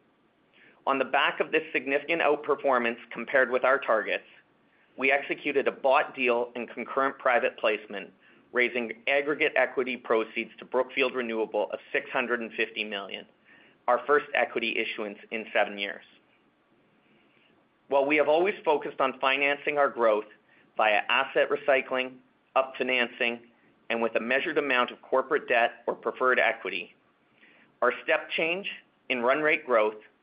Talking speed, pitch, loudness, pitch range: 135 wpm, 130 Hz, -27 LUFS, 120-140 Hz